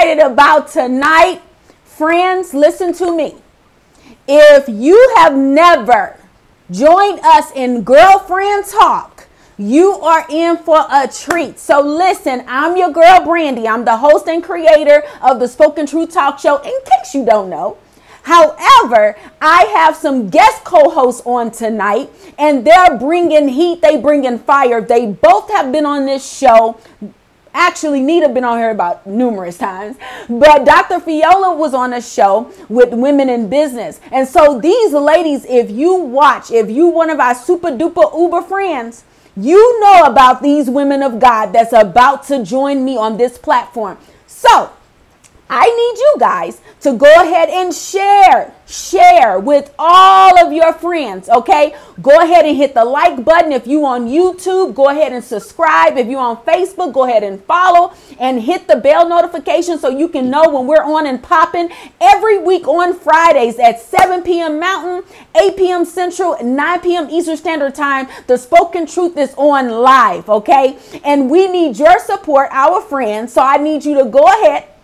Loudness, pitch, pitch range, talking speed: -10 LUFS, 305 Hz, 265-345 Hz, 165 wpm